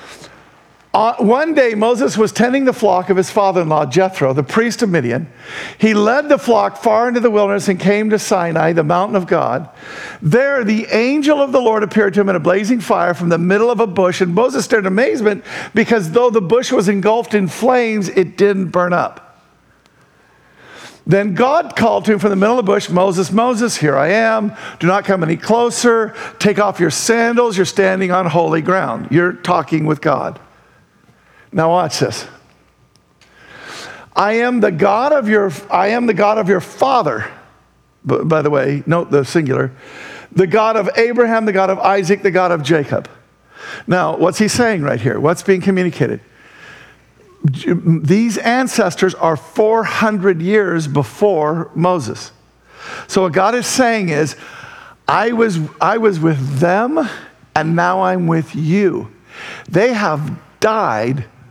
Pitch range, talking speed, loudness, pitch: 170-225 Hz, 170 wpm, -15 LUFS, 195 Hz